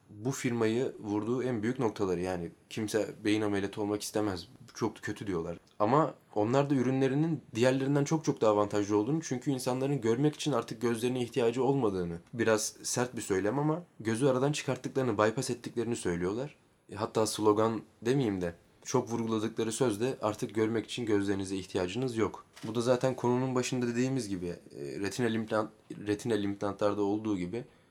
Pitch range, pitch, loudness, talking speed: 105-130 Hz, 115 Hz, -31 LUFS, 155 wpm